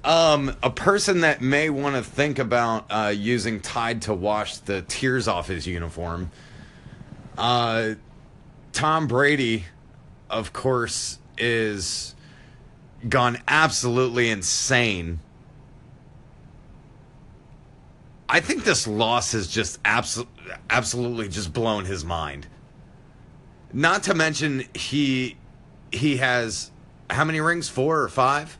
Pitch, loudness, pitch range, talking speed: 120 Hz, -23 LUFS, 105-135 Hz, 110 wpm